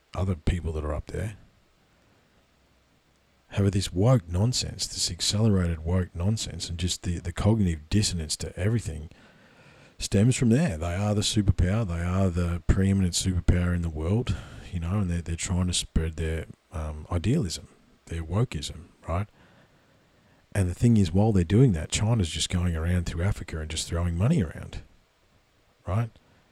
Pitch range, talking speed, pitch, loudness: 85-105 Hz, 160 wpm, 90 Hz, -27 LUFS